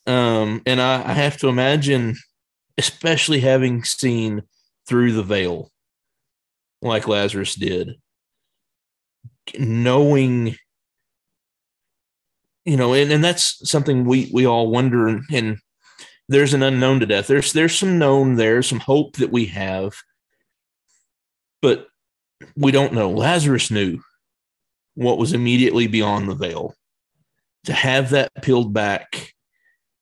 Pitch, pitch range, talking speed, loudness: 125 Hz, 110-140 Hz, 120 wpm, -18 LUFS